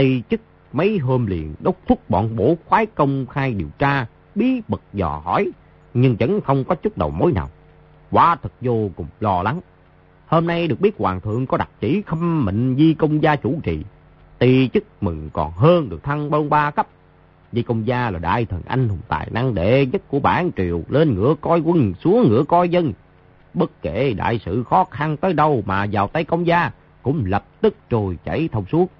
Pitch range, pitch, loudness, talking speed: 100-165 Hz, 130 Hz, -20 LUFS, 210 wpm